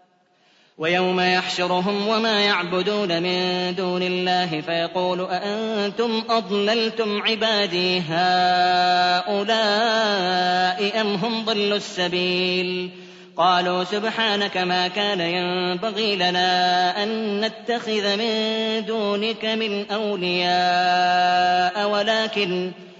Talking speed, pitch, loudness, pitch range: 75 wpm, 185 Hz, -21 LUFS, 180-215 Hz